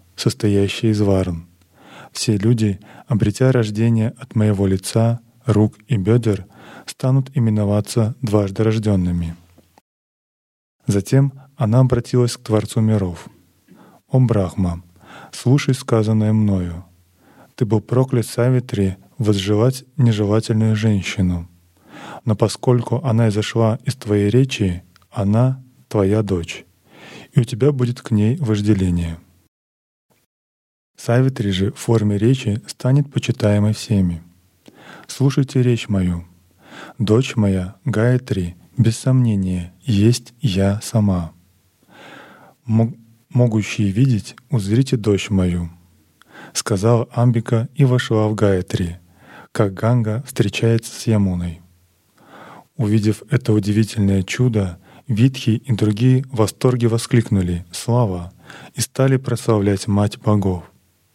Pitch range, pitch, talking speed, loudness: 95-120 Hz, 110 Hz, 100 wpm, -18 LUFS